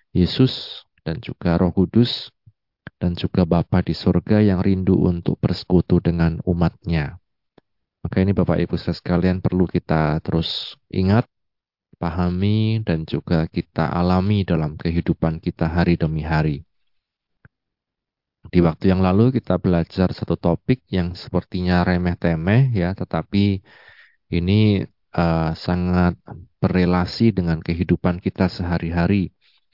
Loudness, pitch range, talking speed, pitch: -20 LUFS, 85-95 Hz, 120 wpm, 90 Hz